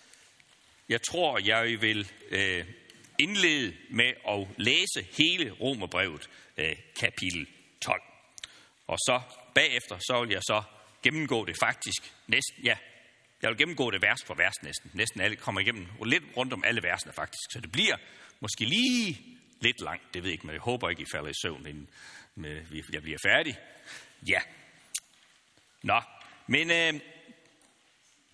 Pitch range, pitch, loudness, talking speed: 95-155 Hz, 115 Hz, -28 LUFS, 150 wpm